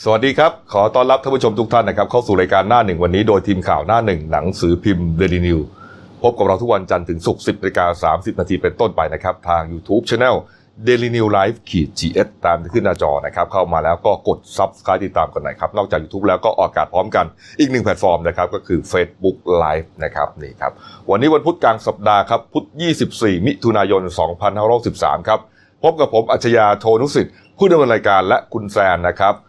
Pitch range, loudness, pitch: 90-115 Hz, -16 LUFS, 100 Hz